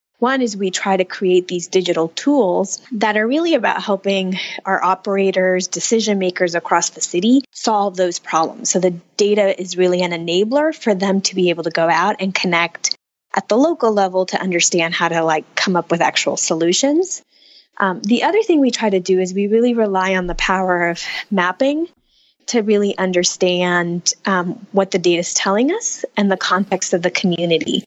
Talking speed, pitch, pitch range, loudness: 190 wpm, 190 Hz, 175-215 Hz, -17 LUFS